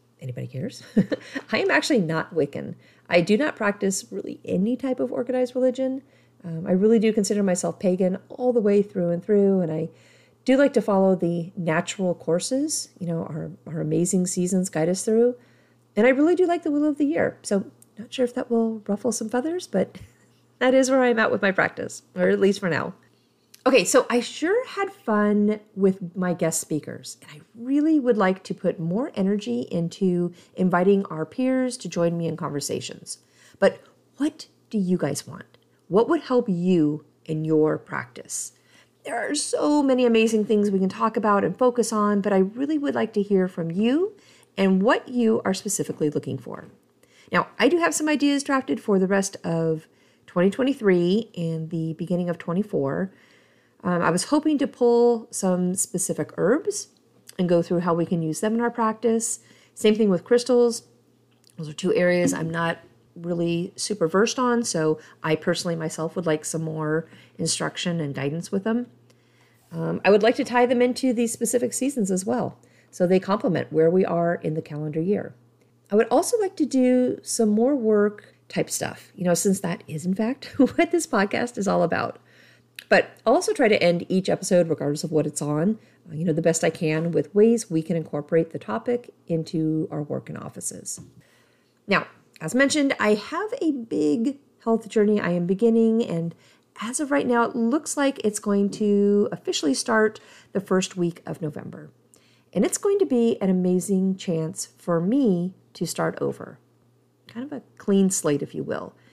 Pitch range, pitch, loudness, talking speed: 170-240 Hz, 200 Hz, -23 LUFS, 190 wpm